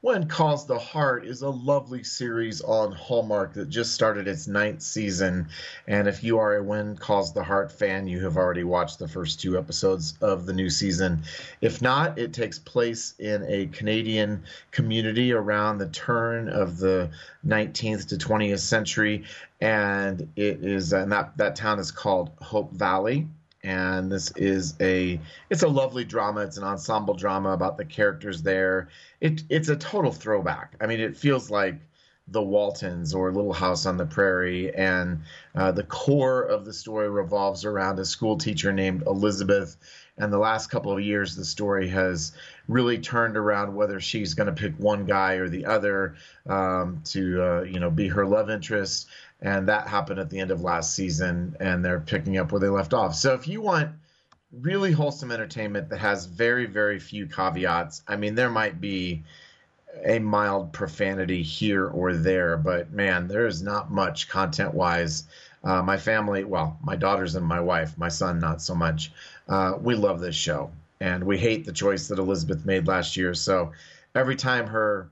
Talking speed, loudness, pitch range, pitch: 180 wpm, -26 LUFS, 90-110 Hz, 100 Hz